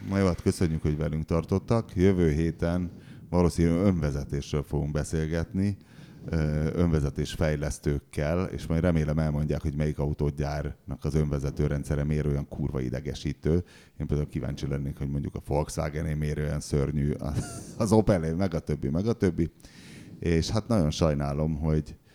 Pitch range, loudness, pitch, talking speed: 75-85 Hz, -28 LUFS, 75 Hz, 145 wpm